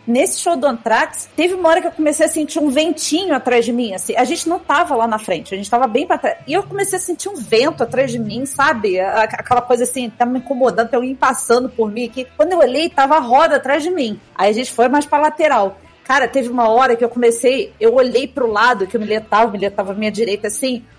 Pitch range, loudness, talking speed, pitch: 235-310 Hz, -16 LUFS, 265 wpm, 260 Hz